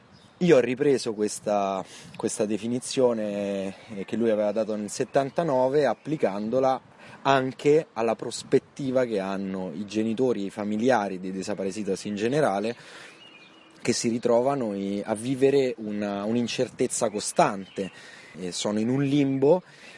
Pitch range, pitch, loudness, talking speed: 100-130 Hz, 110 Hz, -26 LUFS, 115 wpm